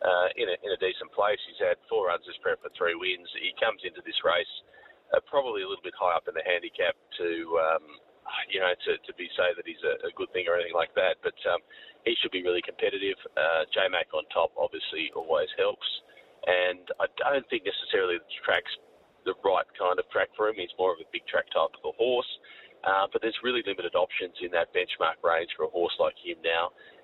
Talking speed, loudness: 230 wpm, -29 LUFS